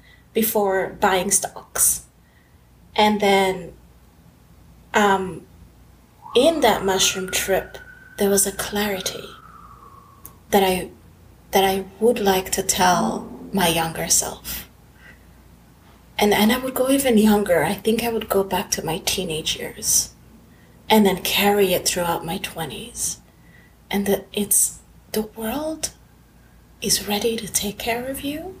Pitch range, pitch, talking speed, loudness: 185-225 Hz, 200 Hz, 130 wpm, -20 LUFS